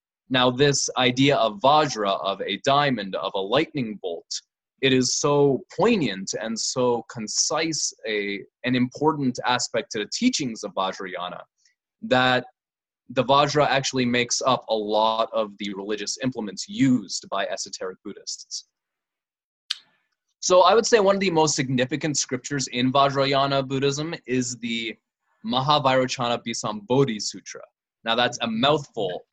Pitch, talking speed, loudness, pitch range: 130 Hz, 135 wpm, -23 LUFS, 120-145 Hz